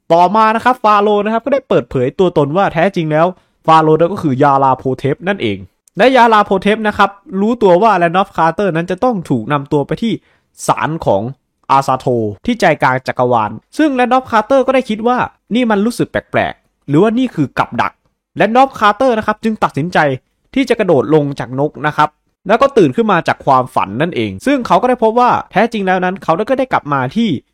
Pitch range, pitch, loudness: 145-225 Hz, 190 Hz, -13 LUFS